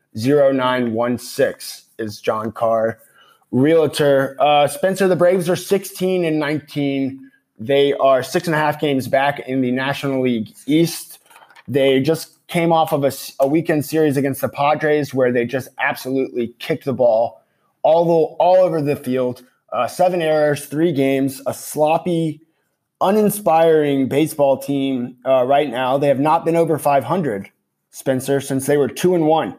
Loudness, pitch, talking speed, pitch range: -18 LUFS, 140 Hz, 155 wpm, 130-160 Hz